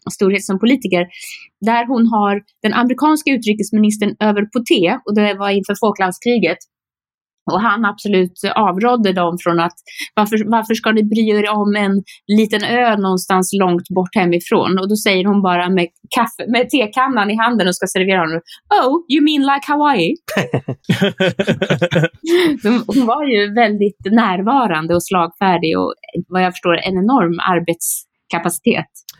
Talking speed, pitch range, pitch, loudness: 150 wpm, 185-230 Hz, 205 Hz, -15 LUFS